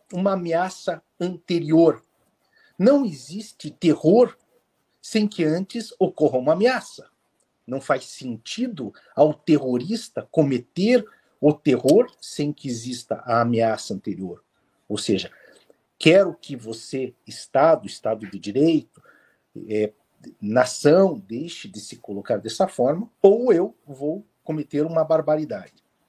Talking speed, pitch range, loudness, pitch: 115 wpm, 125-195 Hz, -22 LUFS, 155 Hz